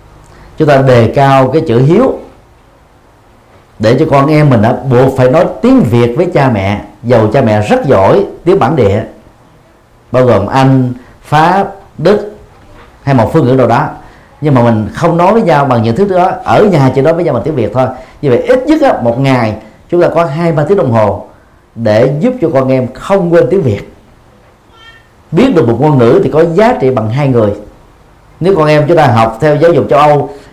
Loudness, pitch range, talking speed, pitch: -9 LUFS, 115-160 Hz, 210 wpm, 130 Hz